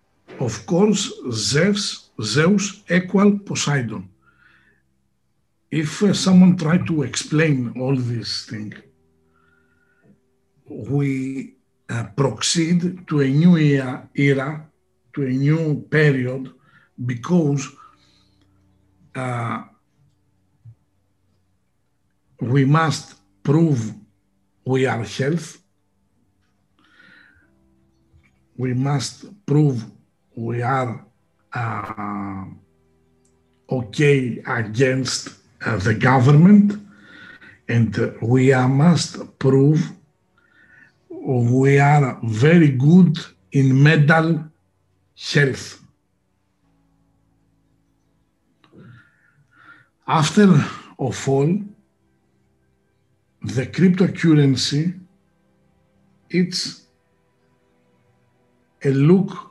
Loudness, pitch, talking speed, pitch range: -19 LUFS, 130 Hz, 70 wpm, 100-155 Hz